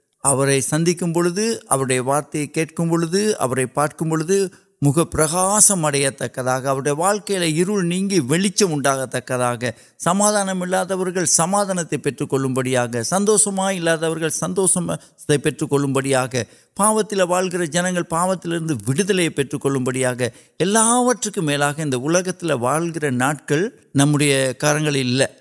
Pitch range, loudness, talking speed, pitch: 135-185 Hz, -19 LUFS, 65 wpm, 160 Hz